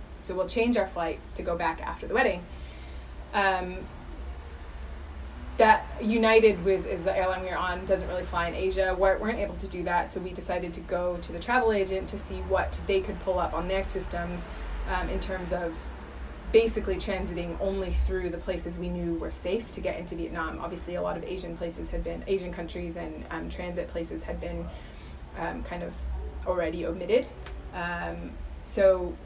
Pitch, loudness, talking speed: 175 Hz, -29 LUFS, 190 wpm